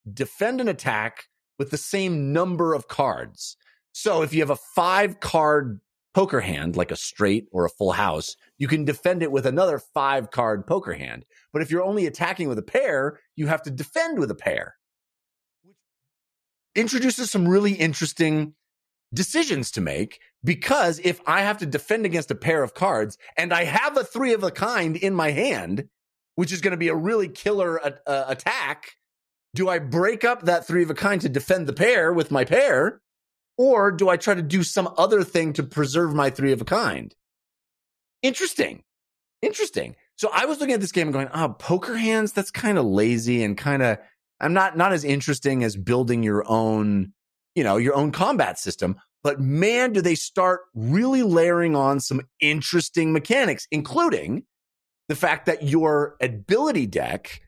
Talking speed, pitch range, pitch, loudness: 185 wpm, 140-200 Hz, 170 Hz, -23 LUFS